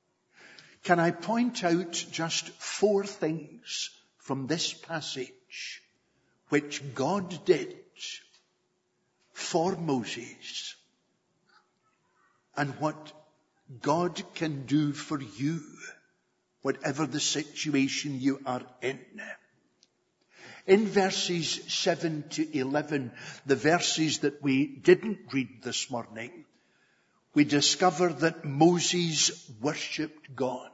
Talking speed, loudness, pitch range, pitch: 90 wpm, -29 LUFS, 140-175 Hz, 155 Hz